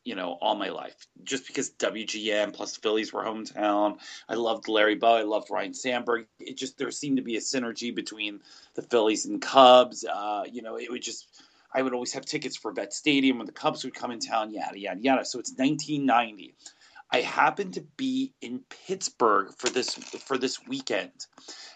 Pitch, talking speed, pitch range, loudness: 125 Hz, 200 wpm, 110-150 Hz, -27 LUFS